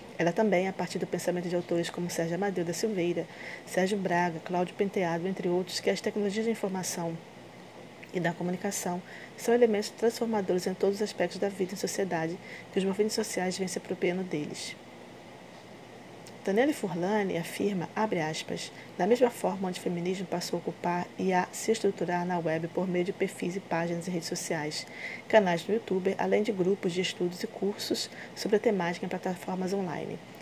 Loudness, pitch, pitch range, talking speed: -30 LUFS, 185 Hz, 175-205 Hz, 180 wpm